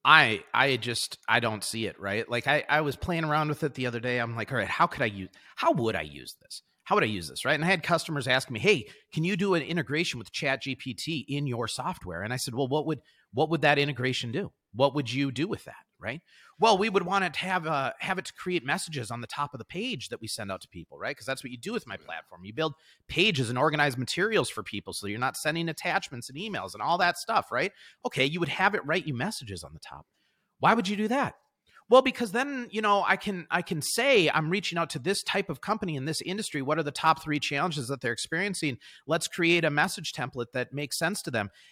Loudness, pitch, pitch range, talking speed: -28 LUFS, 150 Hz, 125-175 Hz, 265 wpm